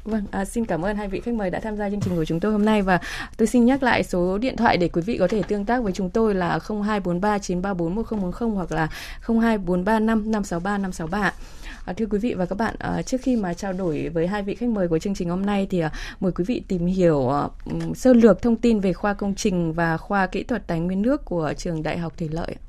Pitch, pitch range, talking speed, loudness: 195 Hz, 175-220 Hz, 245 wpm, -23 LUFS